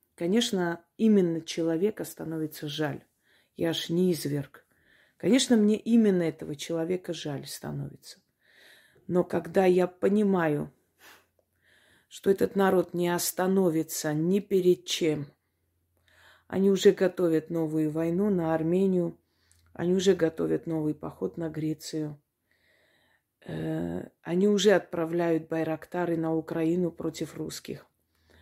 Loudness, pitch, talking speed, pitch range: -27 LUFS, 165 Hz, 110 wpm, 155-180 Hz